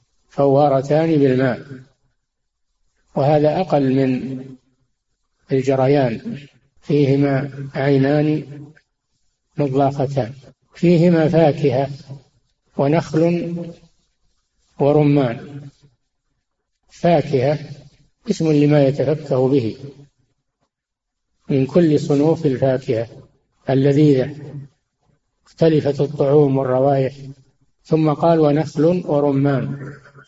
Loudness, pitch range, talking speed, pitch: -17 LUFS, 135-150 Hz, 60 wpm, 140 Hz